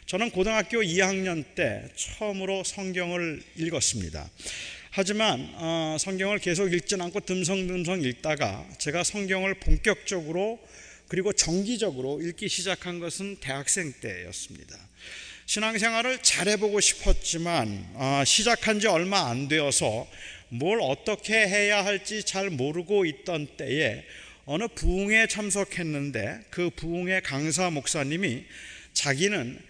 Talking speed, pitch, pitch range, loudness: 275 characters per minute, 185 Hz, 160-205 Hz, -26 LUFS